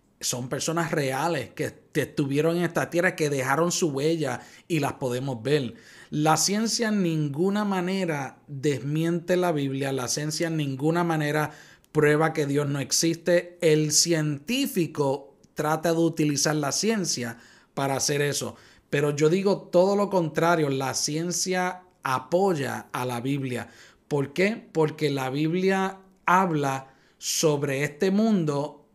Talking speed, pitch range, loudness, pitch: 135 wpm, 140-175 Hz, -25 LUFS, 155 Hz